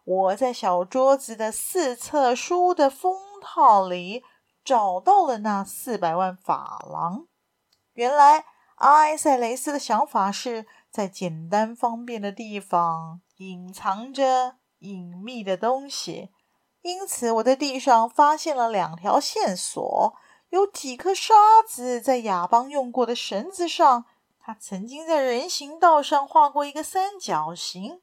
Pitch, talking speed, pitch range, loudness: 245 Hz, 195 characters per minute, 205-295 Hz, -22 LUFS